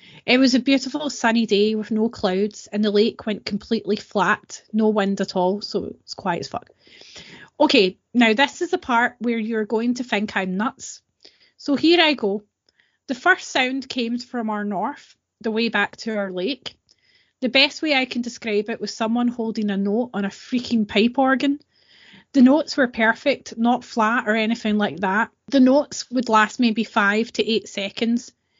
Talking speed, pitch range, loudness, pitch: 190 wpm, 210-255 Hz, -21 LUFS, 225 Hz